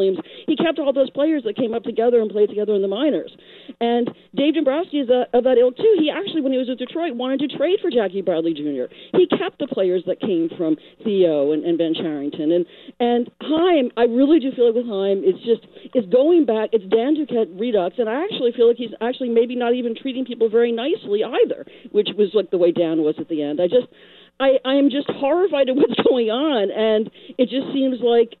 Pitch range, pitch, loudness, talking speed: 210-280 Hz, 240 Hz, -20 LUFS, 230 wpm